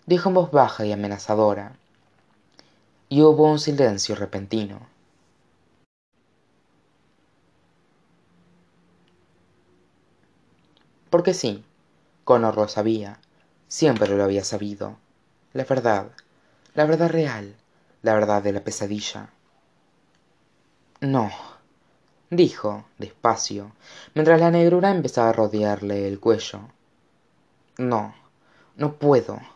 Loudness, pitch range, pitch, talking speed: -21 LUFS, 105-150 Hz, 110 Hz, 90 wpm